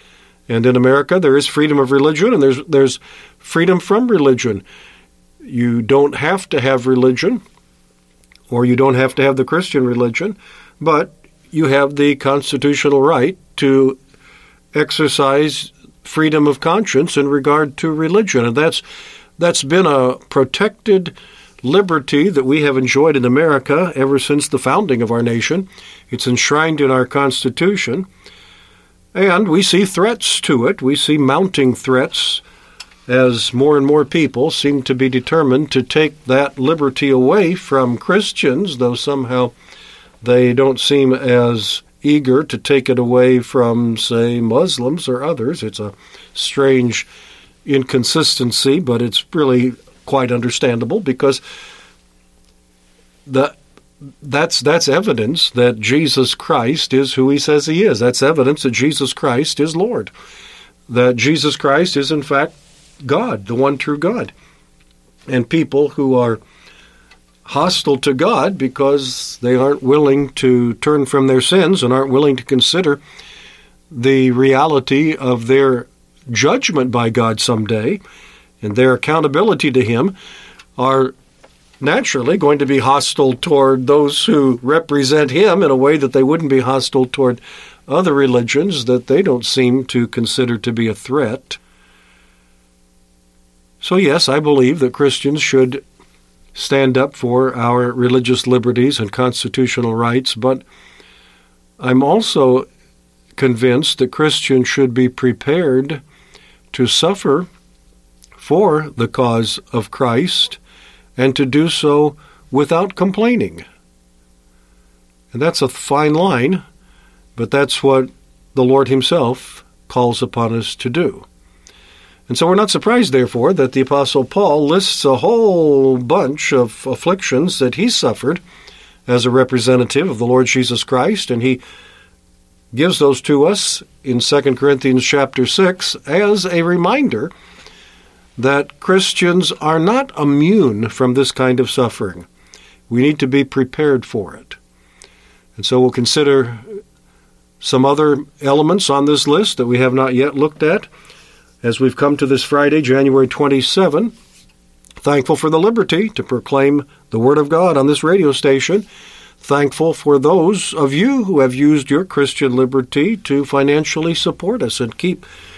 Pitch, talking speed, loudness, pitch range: 135 Hz, 140 wpm, -14 LUFS, 125-150 Hz